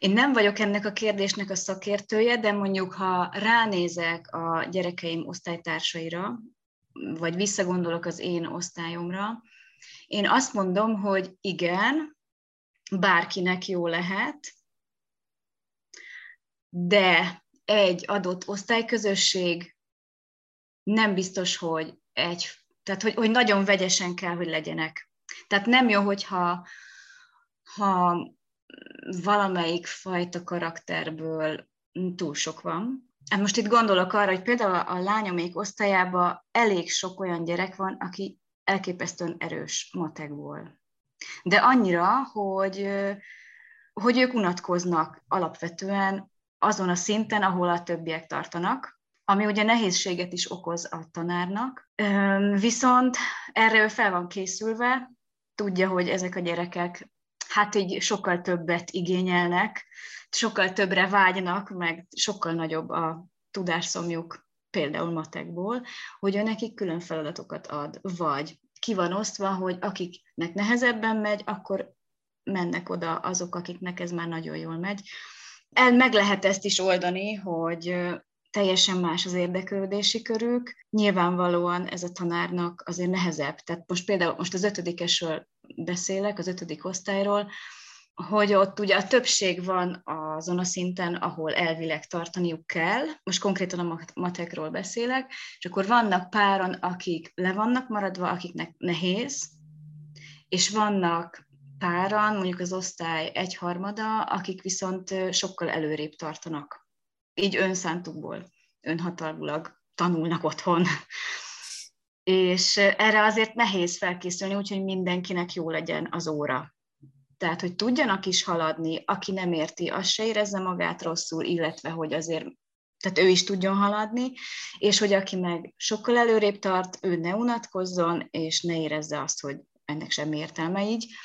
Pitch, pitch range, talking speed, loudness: 185 Hz, 170-205 Hz, 125 wpm, -26 LUFS